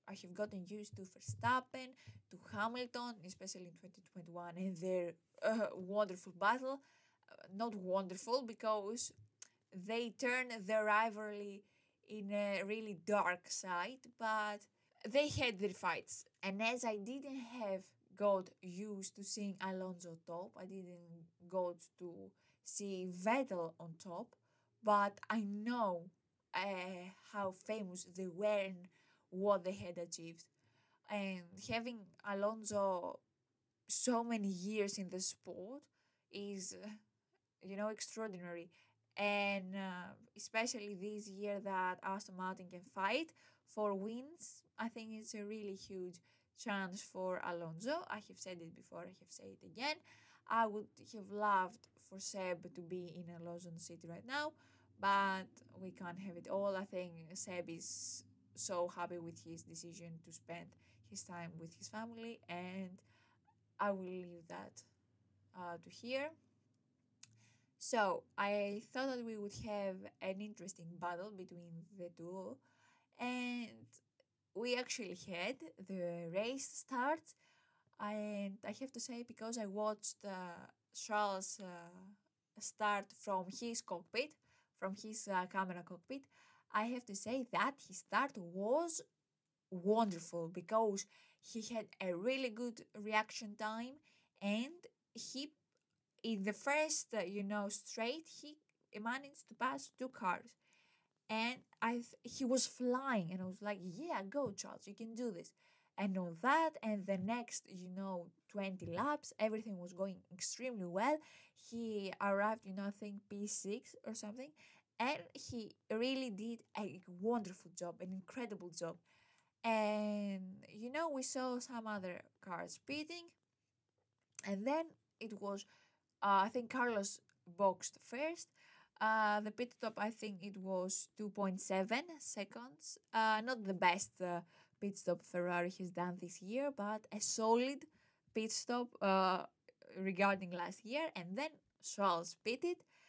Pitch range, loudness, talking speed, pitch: 180-230 Hz, -42 LUFS, 140 wpm, 200 Hz